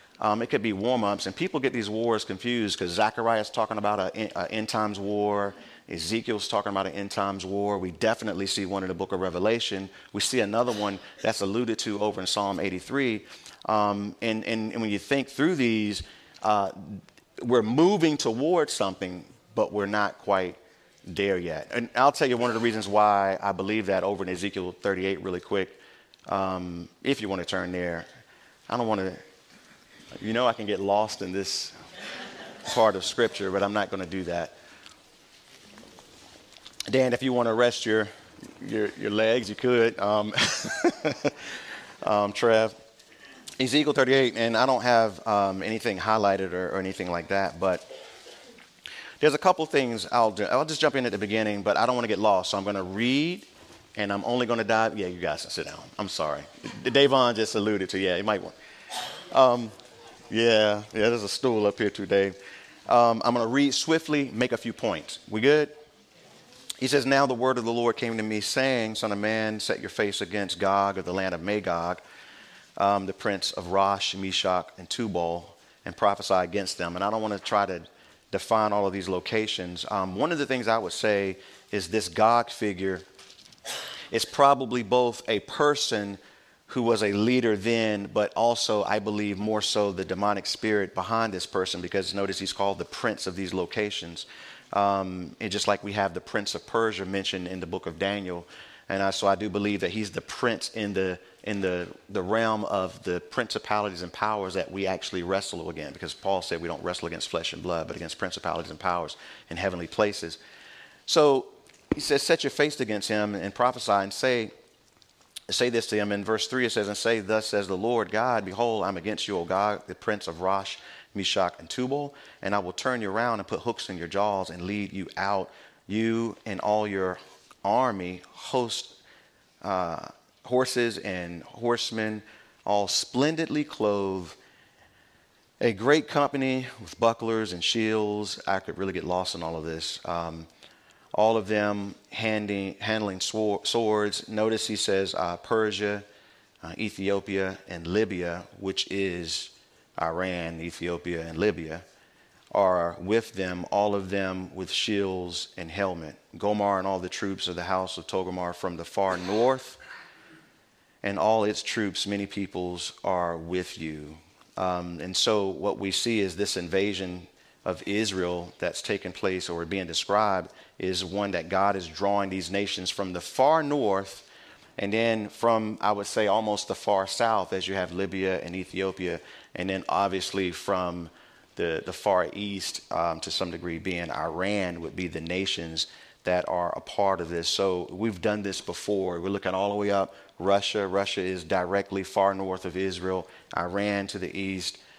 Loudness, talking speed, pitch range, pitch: -27 LUFS, 185 wpm, 95-110 Hz, 100 Hz